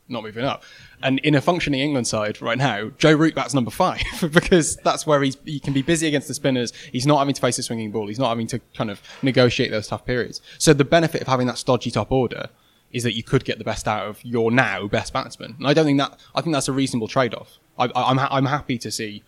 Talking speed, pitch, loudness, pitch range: 270 wpm, 130 Hz, -21 LUFS, 115-140 Hz